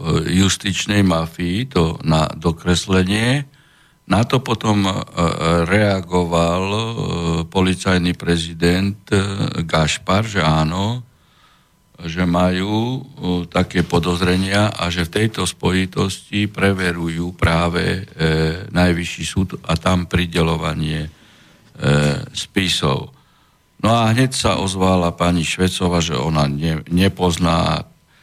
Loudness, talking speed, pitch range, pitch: -18 LUFS, 85 wpm, 85-100 Hz, 90 Hz